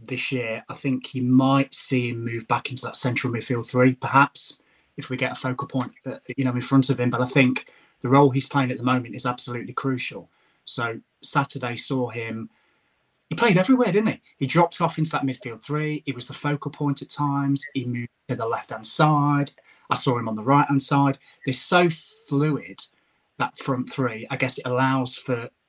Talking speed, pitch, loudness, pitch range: 215 wpm, 135 Hz, -24 LUFS, 125-140 Hz